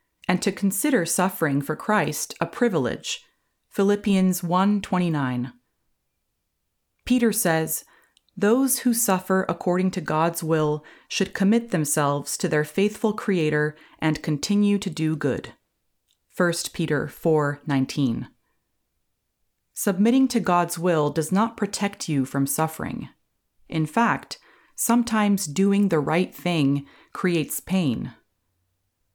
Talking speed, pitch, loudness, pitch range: 110 wpm, 175 Hz, -23 LUFS, 150-200 Hz